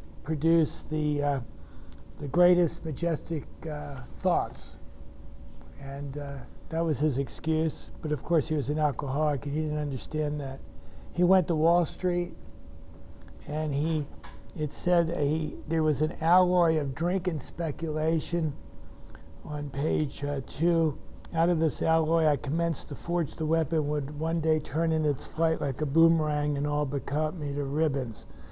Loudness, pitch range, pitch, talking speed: -28 LUFS, 145-165 Hz, 155 Hz, 160 wpm